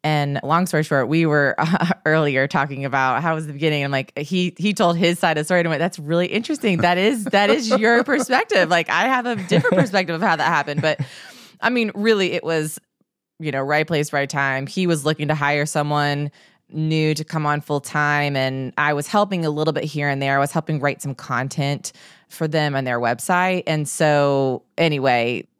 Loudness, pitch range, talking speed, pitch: -20 LUFS, 145-180 Hz, 220 wpm, 155 Hz